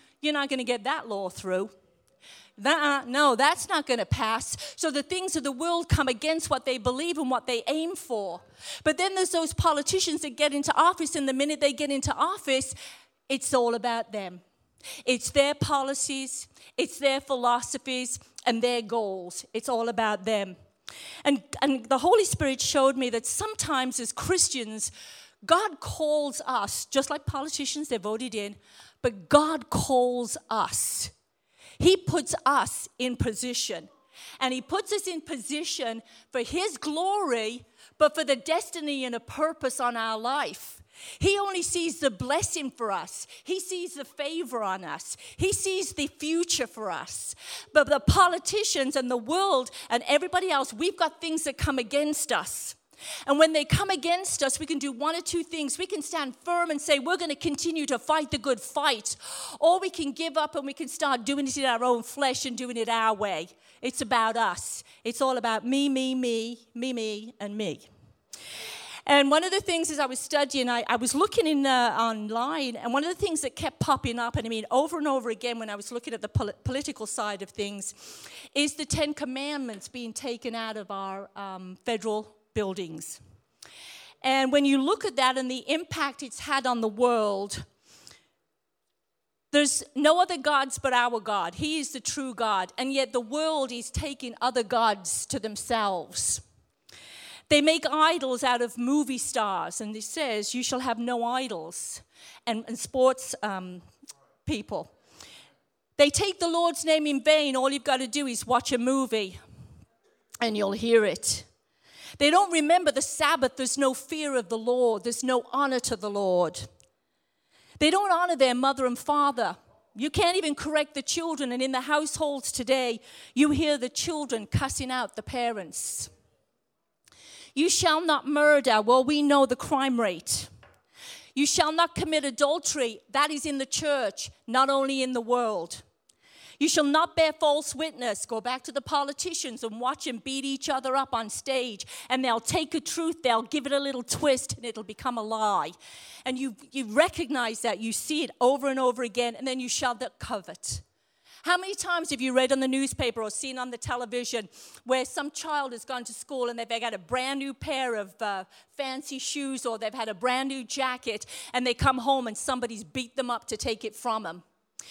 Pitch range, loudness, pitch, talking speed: 235-300 Hz, -27 LUFS, 265 Hz, 185 wpm